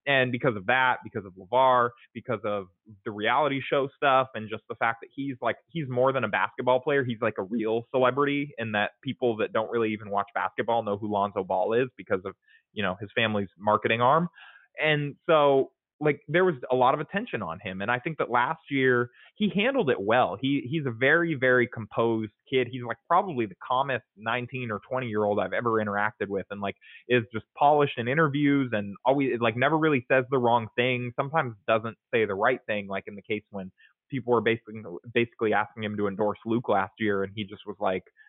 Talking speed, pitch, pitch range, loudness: 215 wpm, 120 Hz, 105-135 Hz, -27 LUFS